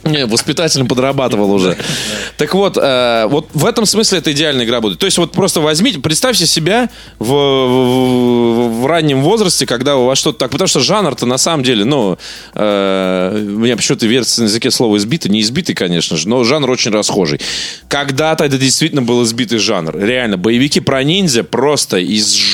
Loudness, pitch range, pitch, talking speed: -12 LUFS, 115-155 Hz, 130 Hz, 180 wpm